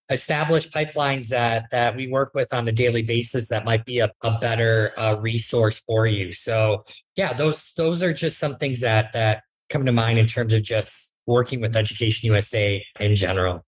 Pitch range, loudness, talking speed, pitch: 110-130 Hz, -21 LUFS, 195 wpm, 115 Hz